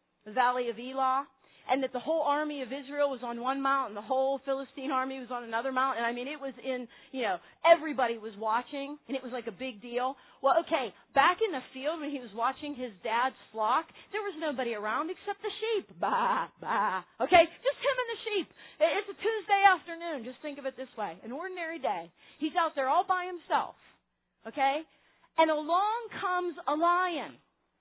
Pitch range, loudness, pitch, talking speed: 255-345 Hz, -31 LUFS, 280 Hz, 205 wpm